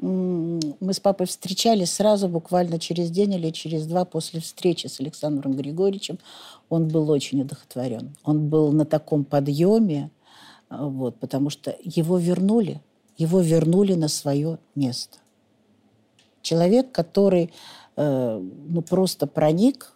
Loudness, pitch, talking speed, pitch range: -23 LUFS, 165 Hz, 120 wpm, 145-180 Hz